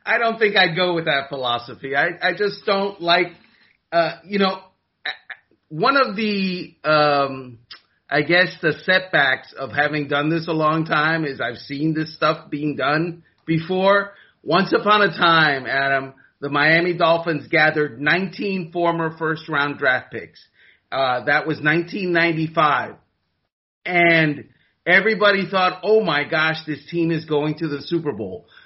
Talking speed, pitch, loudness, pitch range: 150 wpm, 160 Hz, -19 LUFS, 145-180 Hz